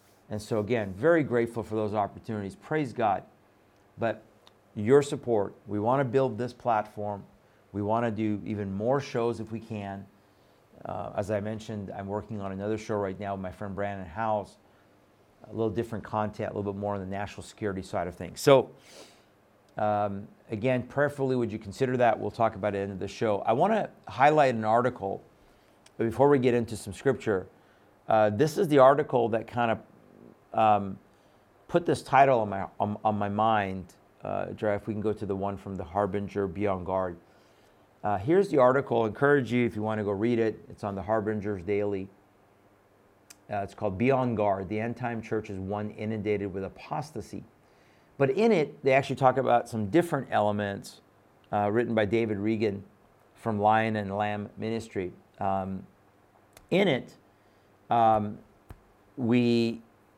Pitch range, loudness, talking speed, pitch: 100-115 Hz, -28 LUFS, 180 wpm, 105 Hz